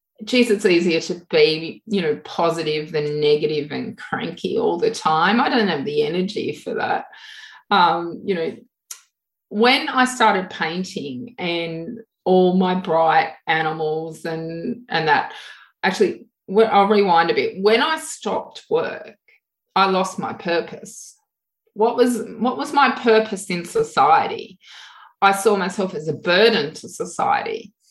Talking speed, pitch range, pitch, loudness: 140 wpm, 175-270 Hz, 215 Hz, -20 LUFS